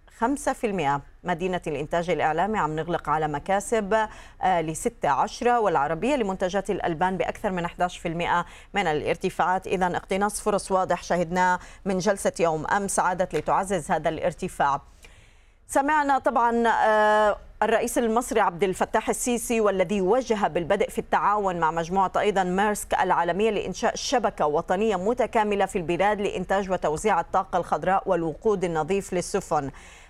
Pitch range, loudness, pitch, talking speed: 175-215 Hz, -25 LUFS, 195 Hz, 120 wpm